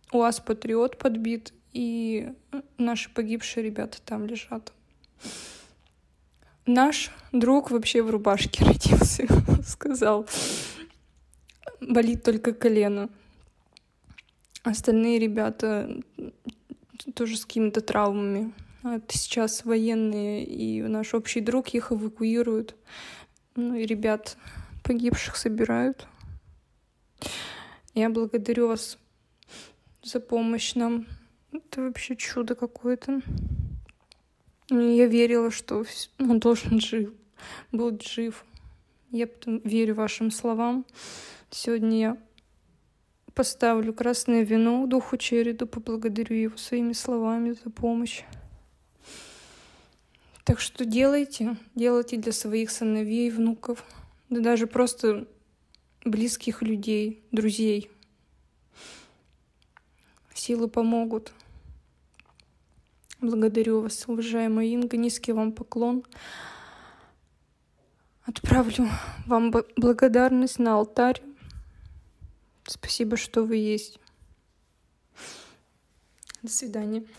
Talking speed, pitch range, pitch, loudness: 85 wpm, 220-240 Hz, 230 Hz, -26 LUFS